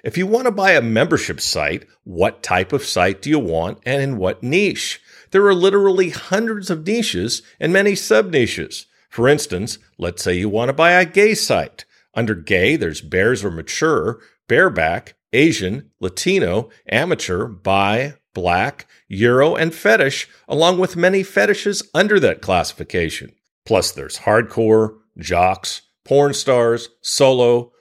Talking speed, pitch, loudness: 150 wpm, 140 Hz, -17 LUFS